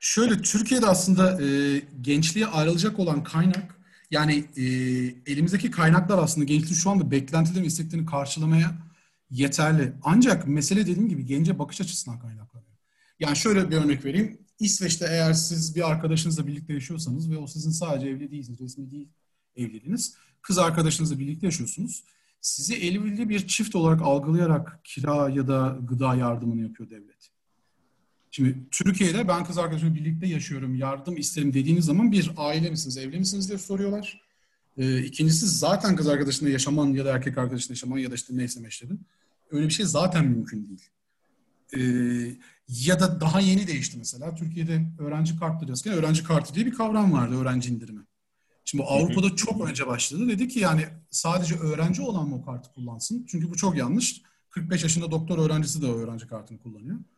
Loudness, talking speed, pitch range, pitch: -25 LUFS, 160 wpm, 135-180 Hz, 160 Hz